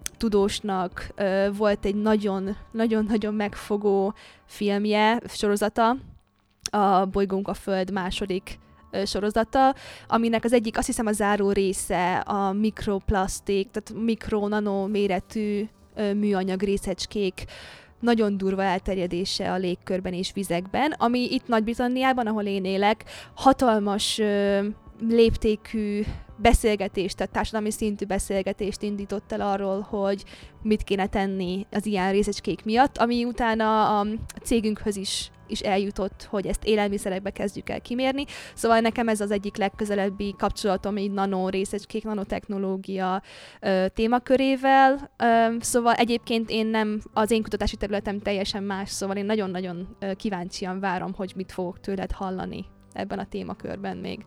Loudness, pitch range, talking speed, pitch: -25 LUFS, 195-220 Hz, 125 wpm, 205 Hz